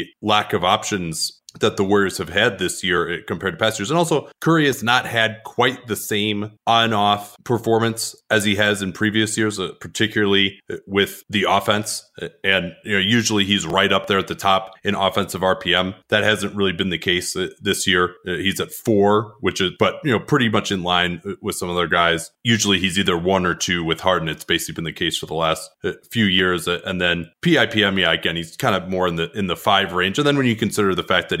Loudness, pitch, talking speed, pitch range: -19 LUFS, 100 Hz, 225 wpm, 90-110 Hz